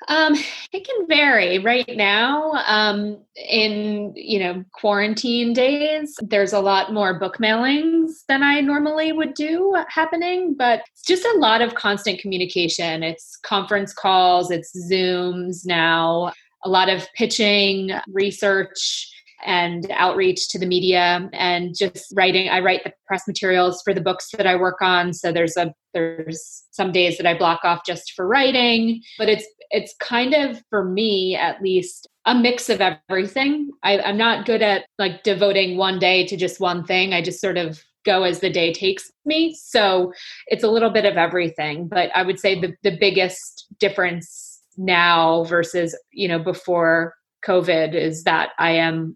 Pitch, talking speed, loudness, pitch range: 195 Hz, 165 wpm, -19 LUFS, 180-230 Hz